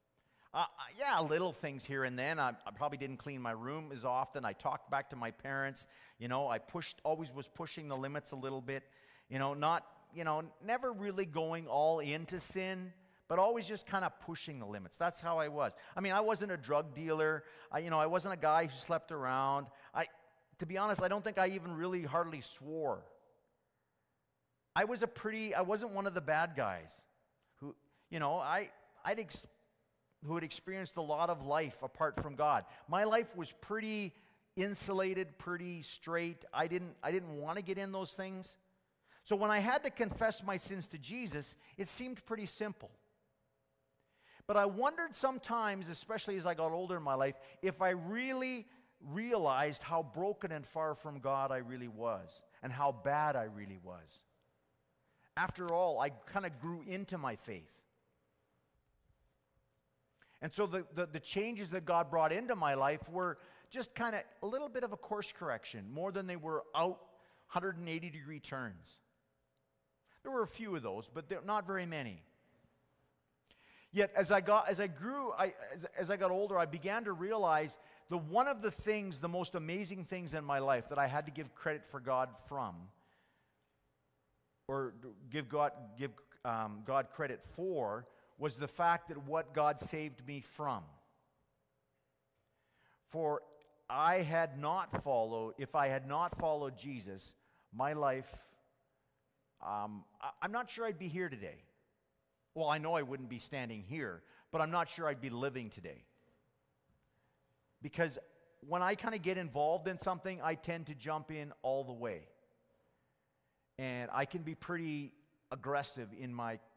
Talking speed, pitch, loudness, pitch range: 175 wpm, 160 Hz, -38 LUFS, 135-190 Hz